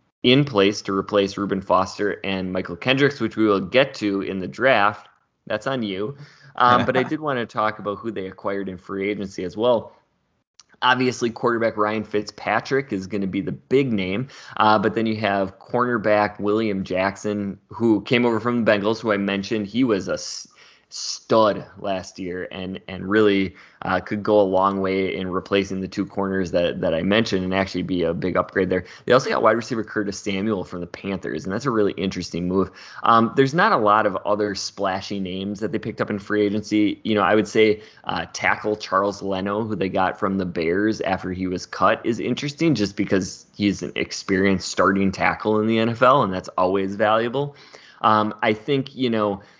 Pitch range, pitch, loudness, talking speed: 95-110 Hz, 105 Hz, -22 LUFS, 200 wpm